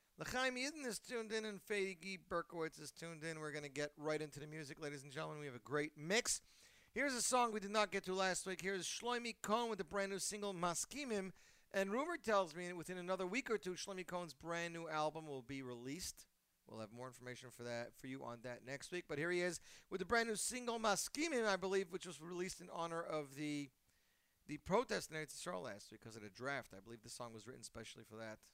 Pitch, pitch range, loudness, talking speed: 170 Hz, 145-200 Hz, -43 LUFS, 245 wpm